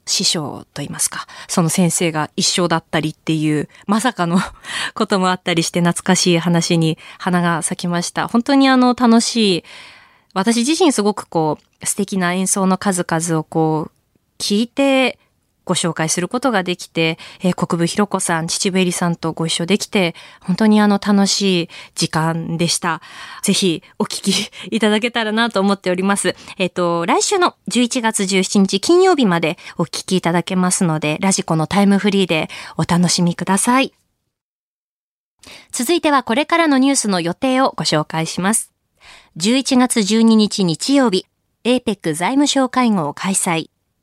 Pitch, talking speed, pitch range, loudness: 190 Hz, 310 characters per minute, 170-225 Hz, -17 LUFS